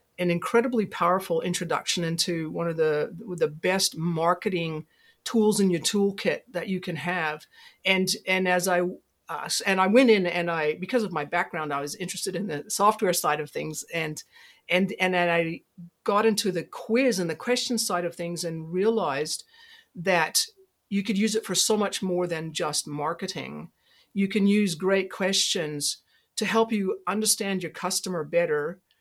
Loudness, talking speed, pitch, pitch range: -26 LUFS, 175 wpm, 185 Hz, 170-210 Hz